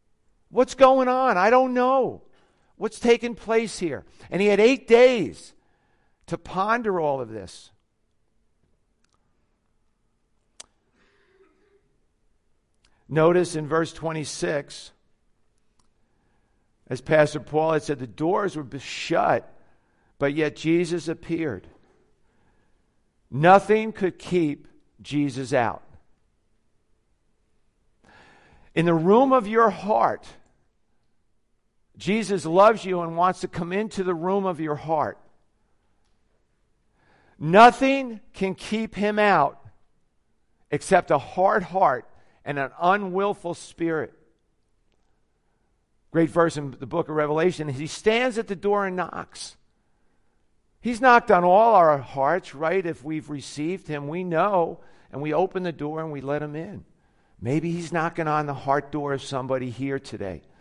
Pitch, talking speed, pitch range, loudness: 160 Hz, 120 wpm, 135-195 Hz, -23 LUFS